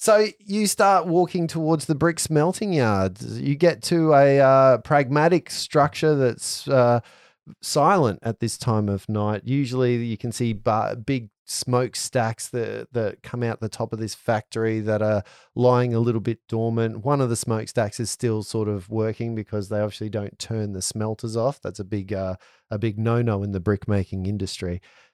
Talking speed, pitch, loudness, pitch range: 185 wpm, 115 Hz, -23 LUFS, 110-140 Hz